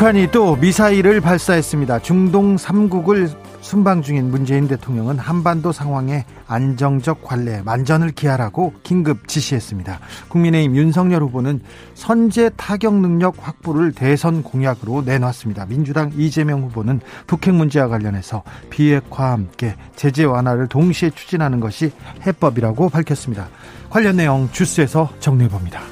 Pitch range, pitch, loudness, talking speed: 125-175 Hz, 145 Hz, -17 LUFS, 340 characters per minute